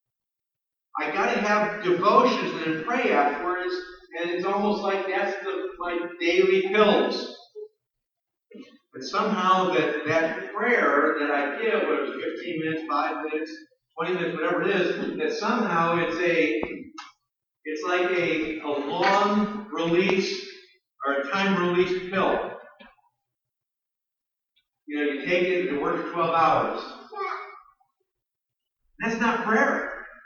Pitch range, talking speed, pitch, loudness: 160-205 Hz, 125 wpm, 180 Hz, -24 LUFS